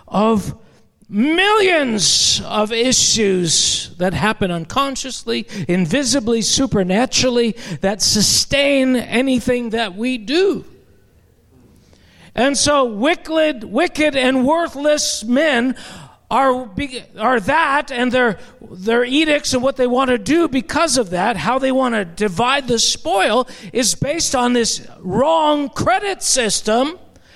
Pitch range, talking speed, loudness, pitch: 215-280 Hz, 110 wpm, -16 LUFS, 250 Hz